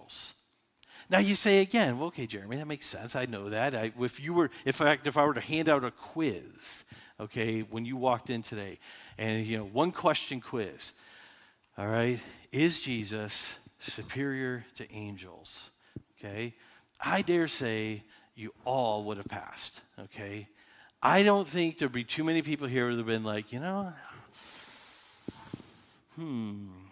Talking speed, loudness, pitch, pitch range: 160 wpm, -31 LUFS, 120 Hz, 110-150 Hz